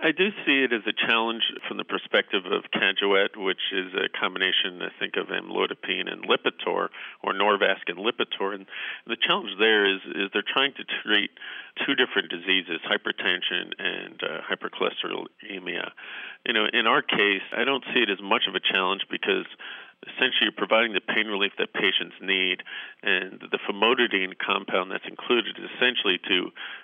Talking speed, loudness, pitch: 170 wpm, -25 LUFS, 160 Hz